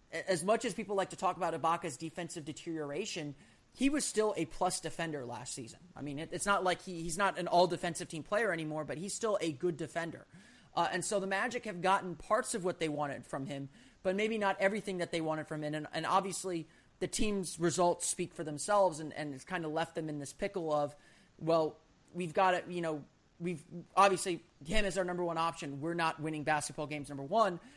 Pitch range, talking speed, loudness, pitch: 155-190 Hz, 225 wpm, -35 LUFS, 170 Hz